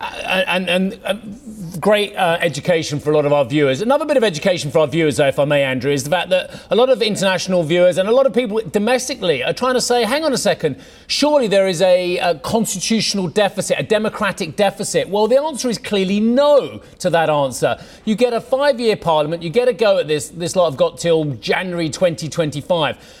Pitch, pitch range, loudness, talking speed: 190 Hz, 170-225 Hz, -17 LUFS, 220 wpm